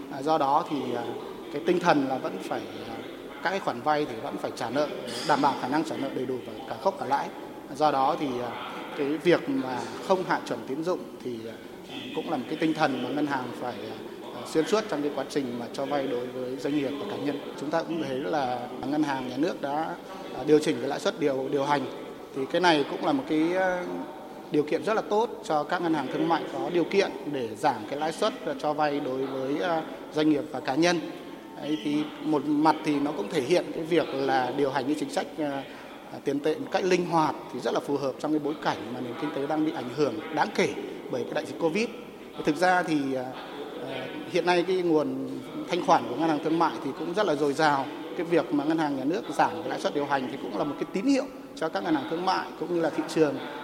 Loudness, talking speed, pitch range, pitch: -28 LUFS, 245 wpm, 140-175 Hz, 155 Hz